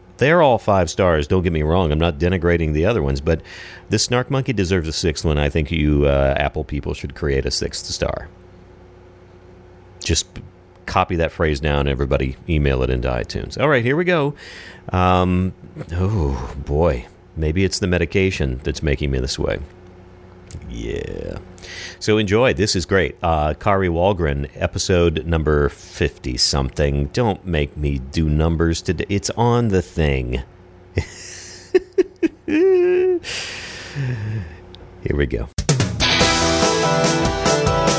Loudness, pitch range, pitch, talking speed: -19 LUFS, 75-95 Hz, 90 Hz, 135 wpm